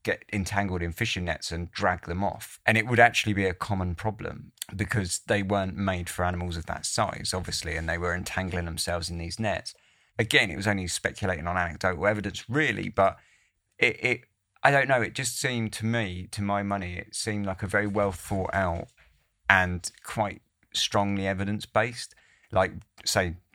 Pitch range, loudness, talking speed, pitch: 90-105 Hz, -27 LUFS, 185 wpm, 95 Hz